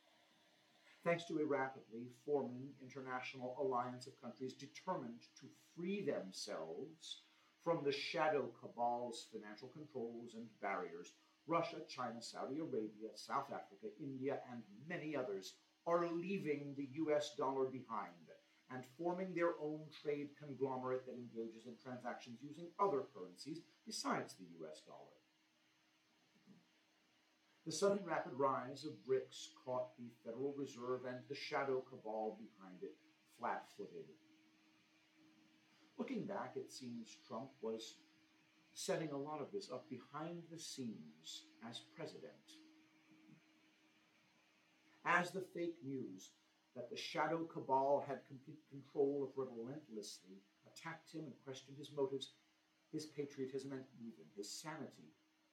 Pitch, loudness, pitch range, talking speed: 140 Hz, -45 LUFS, 125-160 Hz, 120 wpm